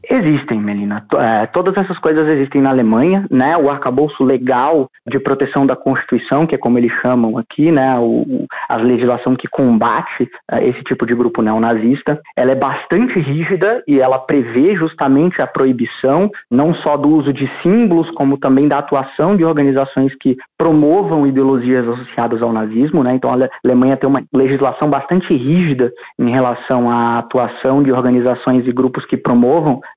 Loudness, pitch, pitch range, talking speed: -14 LUFS, 135 Hz, 125-150 Hz, 160 wpm